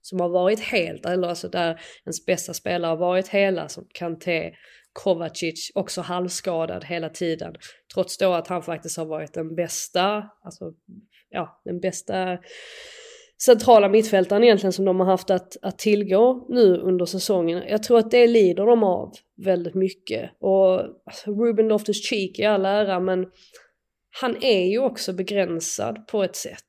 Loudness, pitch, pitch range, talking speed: -22 LUFS, 190 Hz, 175-210 Hz, 160 wpm